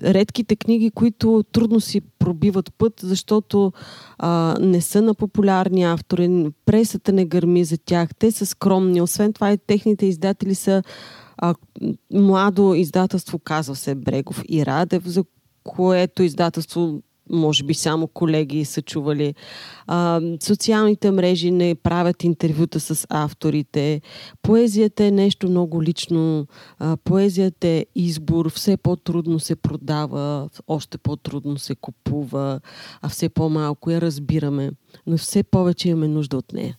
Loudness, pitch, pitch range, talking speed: -20 LUFS, 175 Hz, 155-195 Hz, 130 wpm